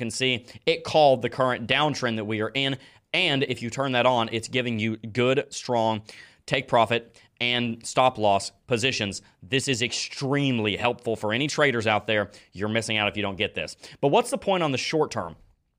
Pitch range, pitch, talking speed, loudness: 110-135 Hz, 120 Hz, 200 wpm, -25 LUFS